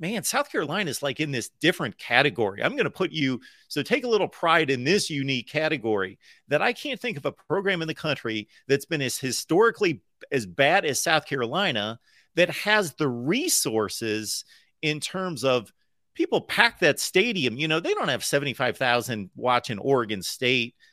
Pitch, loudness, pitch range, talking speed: 140 Hz, -25 LUFS, 120-170 Hz, 180 wpm